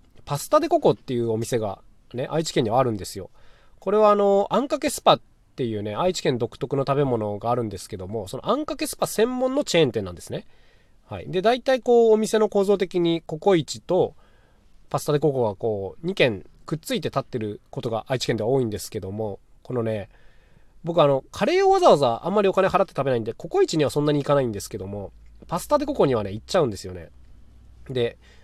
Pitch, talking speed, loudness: 135 Hz, 430 characters per minute, -23 LUFS